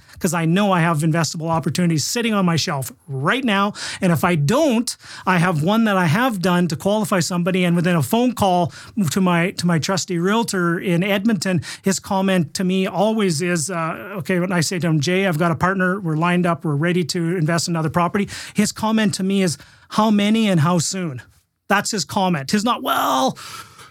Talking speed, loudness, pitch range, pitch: 210 wpm, -19 LUFS, 170-195 Hz, 180 Hz